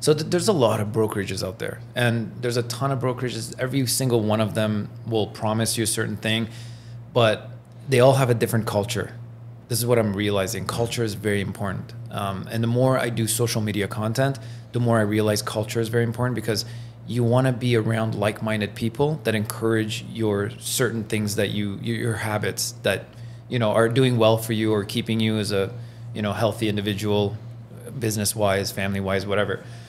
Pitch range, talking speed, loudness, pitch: 105-120 Hz, 195 wpm, -23 LUFS, 115 Hz